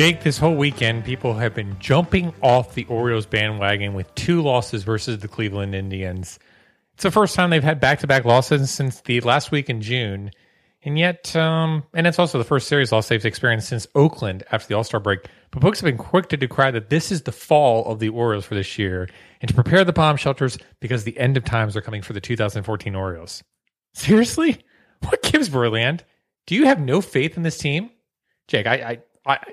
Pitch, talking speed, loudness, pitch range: 125 Hz, 215 wpm, -20 LUFS, 110-155 Hz